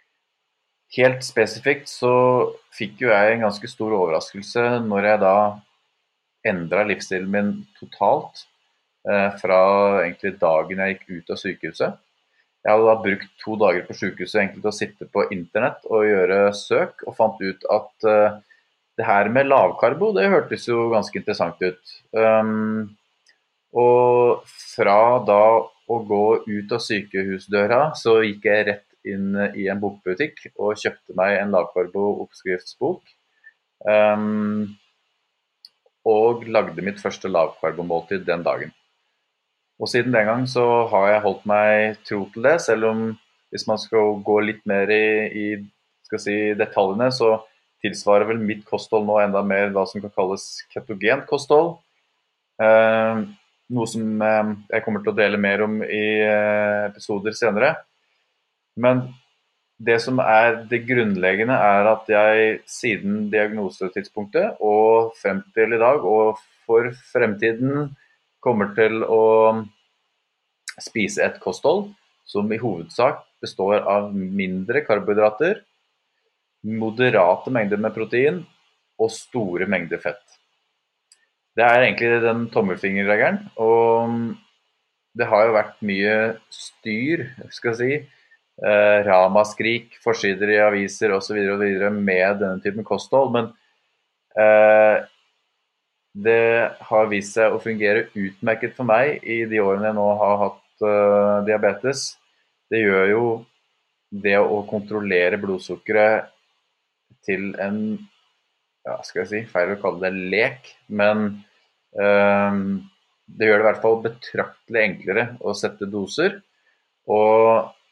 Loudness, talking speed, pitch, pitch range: -20 LUFS, 135 wpm, 105 Hz, 100-115 Hz